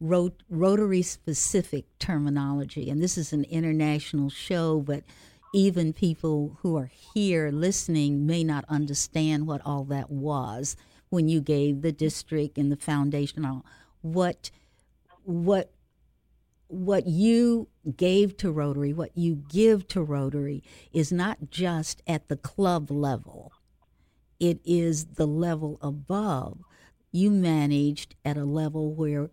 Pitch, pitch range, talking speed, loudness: 155 Hz, 145-175 Hz, 130 wpm, -27 LUFS